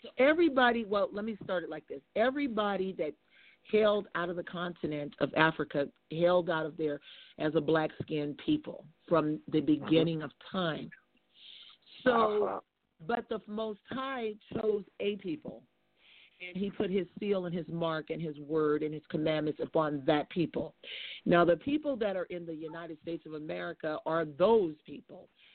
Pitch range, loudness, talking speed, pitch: 155-210 Hz, -32 LUFS, 165 wpm, 175 Hz